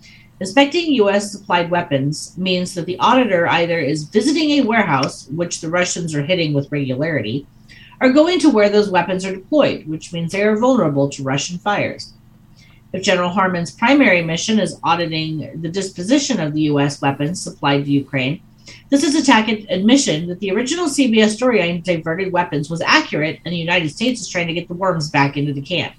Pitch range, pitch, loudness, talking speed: 145-210 Hz, 175 Hz, -17 LUFS, 180 wpm